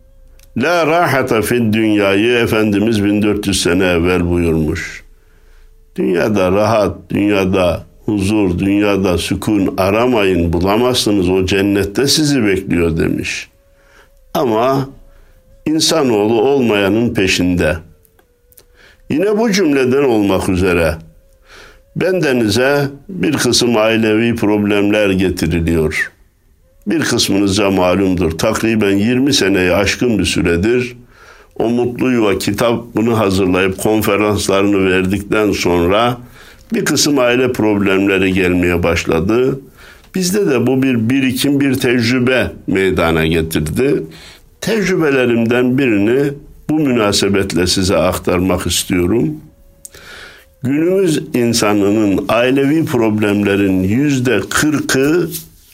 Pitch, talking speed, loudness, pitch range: 100 Hz, 90 wpm, -14 LUFS, 90-120 Hz